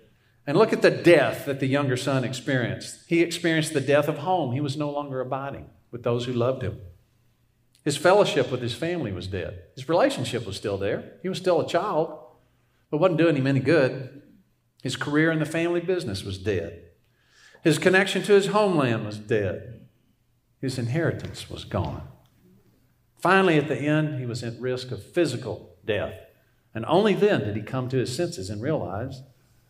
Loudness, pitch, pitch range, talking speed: -24 LUFS, 130 Hz, 120-165 Hz, 180 wpm